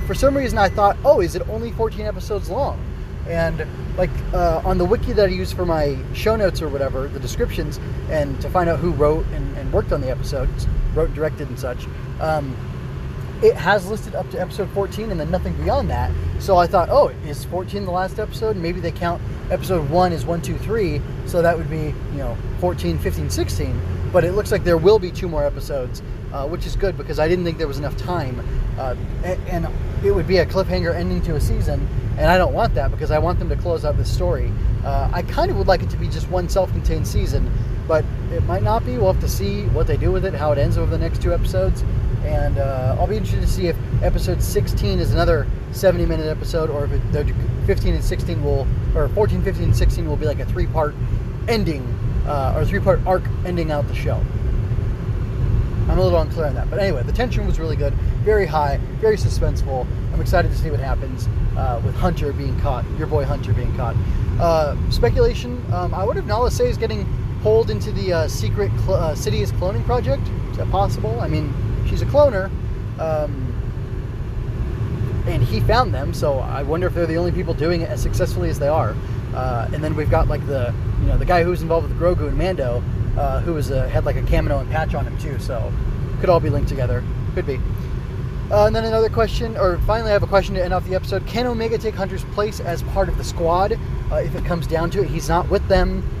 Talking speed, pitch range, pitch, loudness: 230 wpm, 105-150 Hz, 120 Hz, -21 LUFS